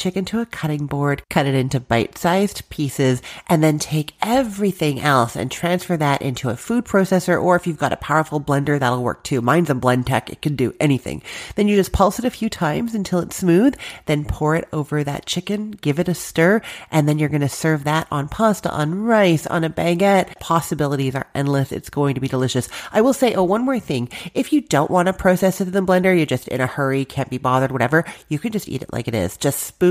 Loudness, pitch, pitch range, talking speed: -19 LUFS, 155 Hz, 140-190 Hz, 240 wpm